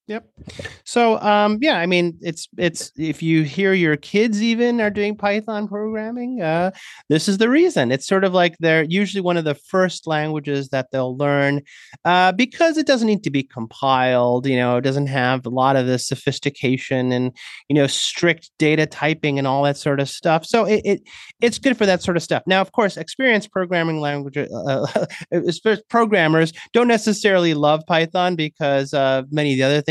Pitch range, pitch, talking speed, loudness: 140-205 Hz, 165 Hz, 195 wpm, -19 LUFS